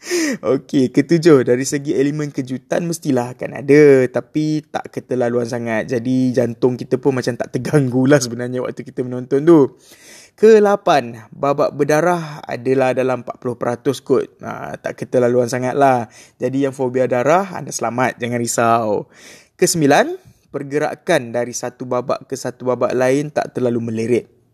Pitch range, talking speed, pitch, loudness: 125-145 Hz, 140 wpm, 130 Hz, -17 LUFS